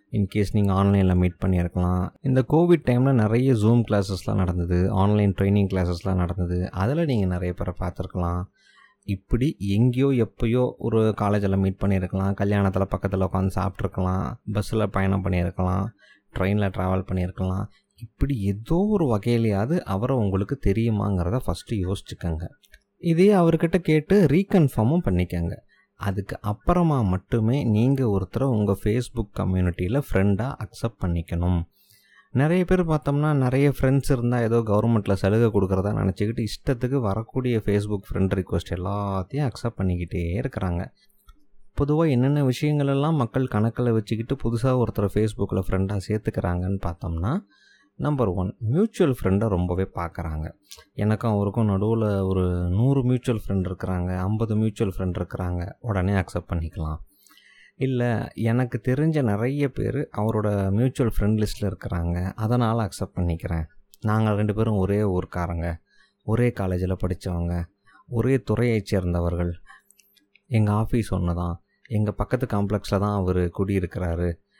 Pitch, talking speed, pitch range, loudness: 105 Hz, 120 wpm, 95-120 Hz, -24 LUFS